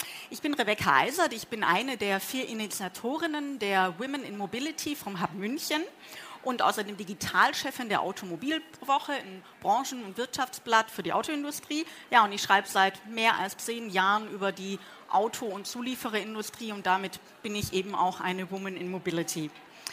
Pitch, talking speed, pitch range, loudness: 215 Hz, 160 wpm, 190-260 Hz, -29 LUFS